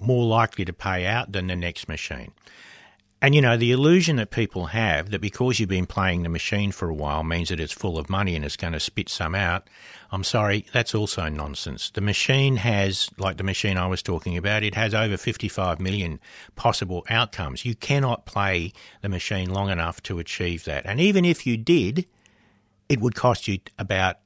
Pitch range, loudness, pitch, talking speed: 90-115 Hz, -24 LUFS, 100 Hz, 205 wpm